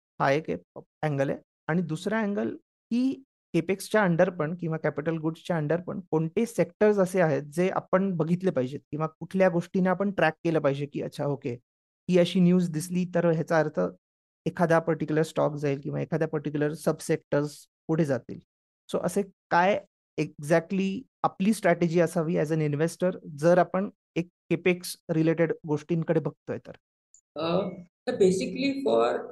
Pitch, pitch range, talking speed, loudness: 165 Hz, 155-180 Hz, 145 wpm, -27 LUFS